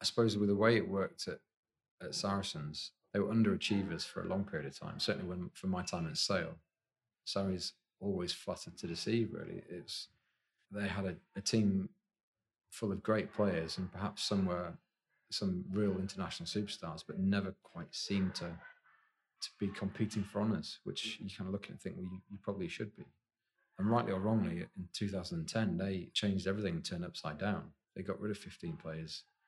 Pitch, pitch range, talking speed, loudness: 100 Hz, 95-110 Hz, 195 wpm, -38 LUFS